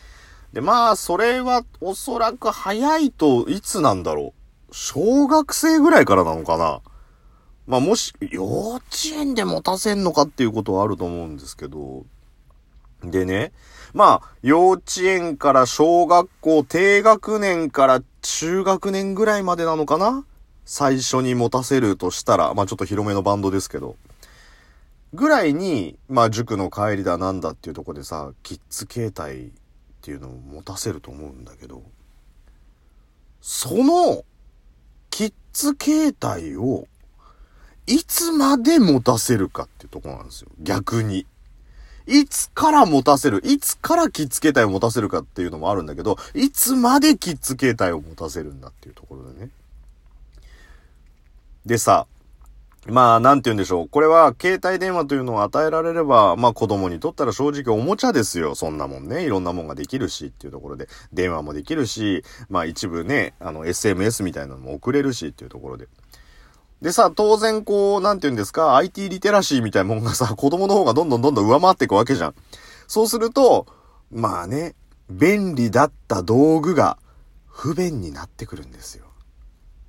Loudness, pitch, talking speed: -19 LUFS, 130 Hz, 335 characters per minute